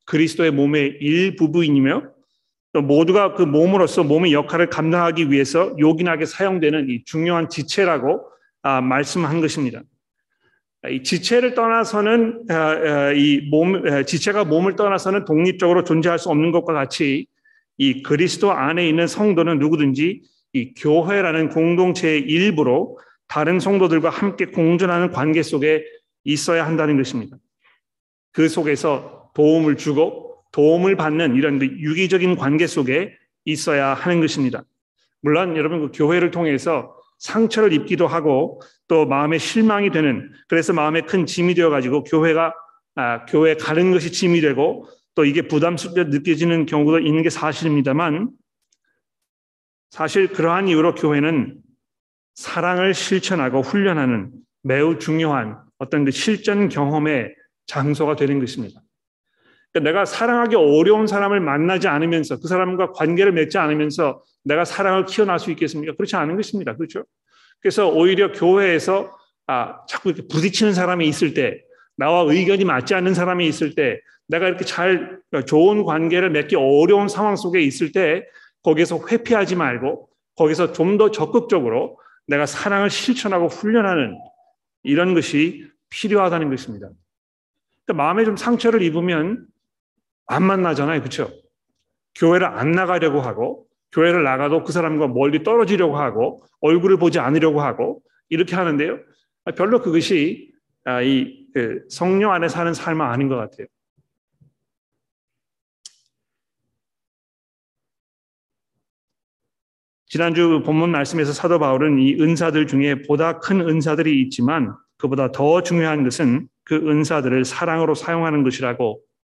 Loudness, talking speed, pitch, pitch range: -18 LUFS, 310 characters per minute, 165 Hz, 150-190 Hz